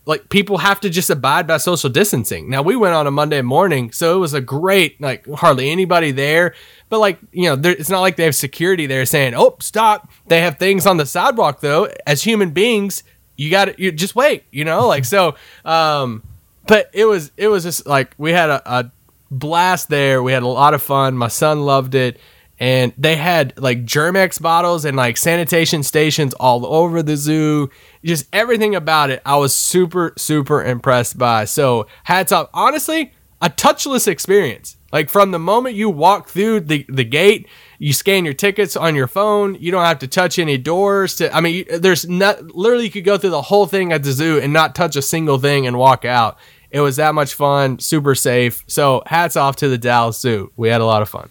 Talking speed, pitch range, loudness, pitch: 215 wpm, 135-185 Hz, -15 LUFS, 160 Hz